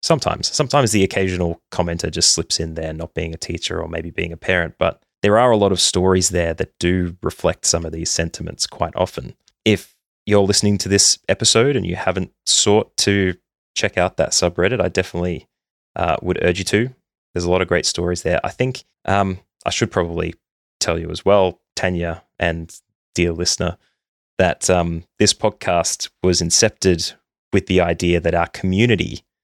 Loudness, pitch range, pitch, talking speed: -18 LUFS, 85-100 Hz, 90 Hz, 185 wpm